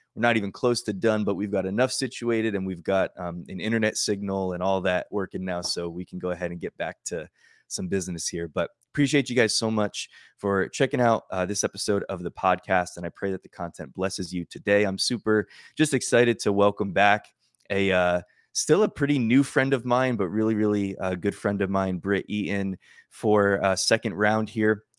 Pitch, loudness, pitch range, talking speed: 100 Hz, -25 LUFS, 95-110 Hz, 215 wpm